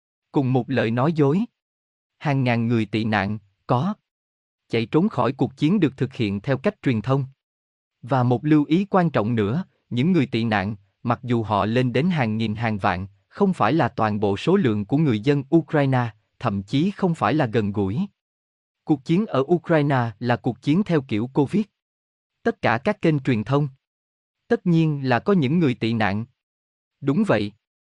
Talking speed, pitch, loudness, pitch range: 185 wpm, 125 Hz, -22 LUFS, 110-155 Hz